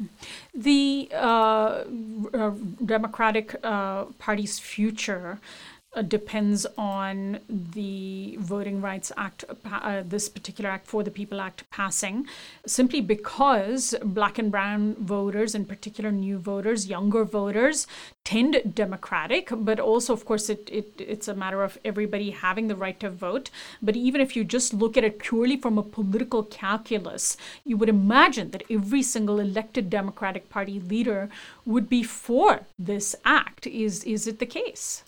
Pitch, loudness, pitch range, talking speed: 215 Hz, -26 LUFS, 200-230 Hz, 150 wpm